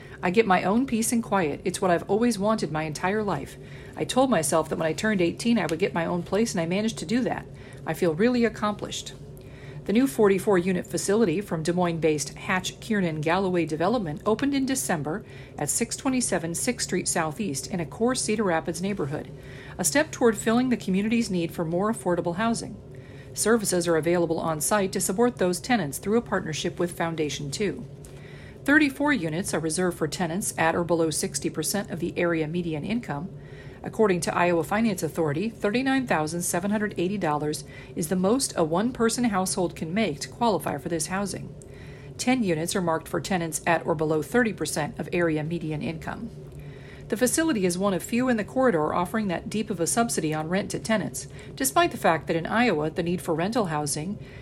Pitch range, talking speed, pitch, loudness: 160-215 Hz, 190 wpm, 180 Hz, -25 LUFS